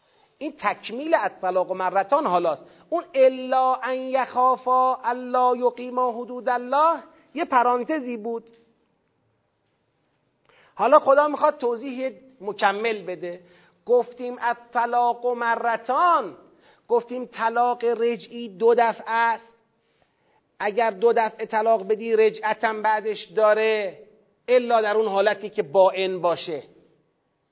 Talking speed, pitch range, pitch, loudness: 105 wpm, 215-250 Hz, 235 Hz, -22 LUFS